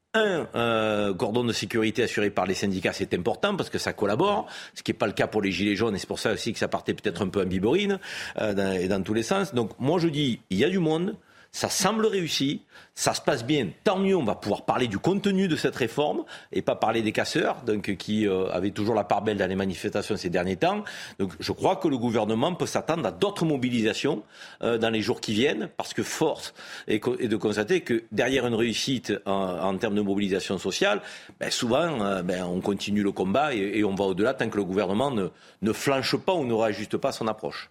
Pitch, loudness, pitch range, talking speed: 110 Hz, -26 LUFS, 100-135 Hz, 240 wpm